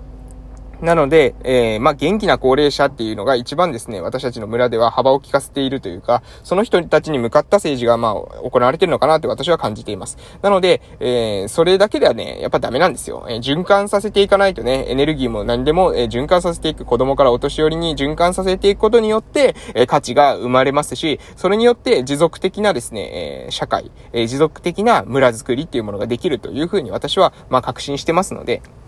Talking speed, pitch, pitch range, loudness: 430 characters per minute, 145 Hz, 125-180 Hz, -17 LUFS